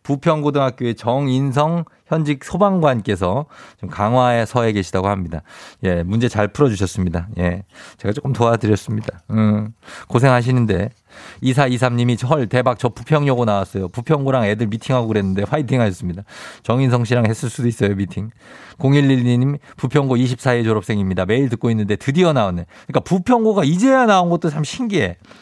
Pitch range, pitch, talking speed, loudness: 105-140 Hz, 120 Hz, 360 characters per minute, -18 LUFS